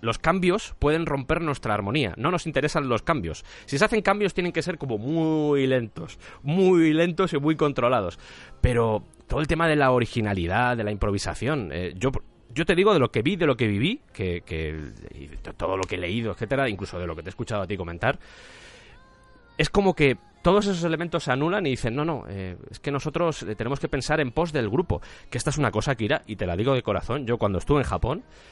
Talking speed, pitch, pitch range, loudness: 225 wpm, 130 Hz, 105-155 Hz, -25 LUFS